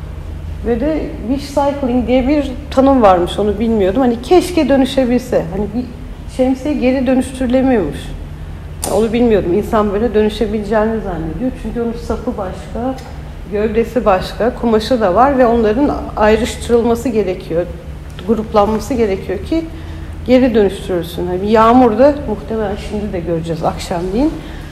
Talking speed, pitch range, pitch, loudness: 120 wpm, 200-255 Hz, 225 Hz, -15 LUFS